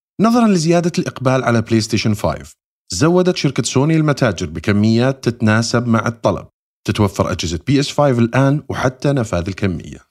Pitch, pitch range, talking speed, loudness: 120 Hz, 105-140 Hz, 135 wpm, -16 LUFS